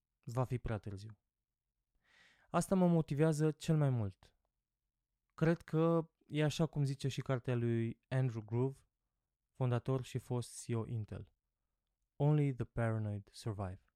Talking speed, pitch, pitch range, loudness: 130 wpm, 125 Hz, 110-145 Hz, -37 LUFS